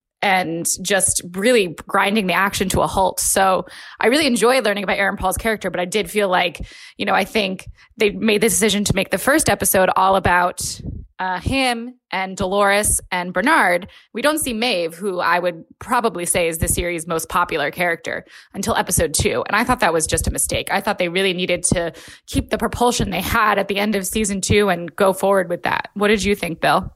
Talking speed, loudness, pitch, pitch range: 215 wpm, -18 LUFS, 195 Hz, 180-210 Hz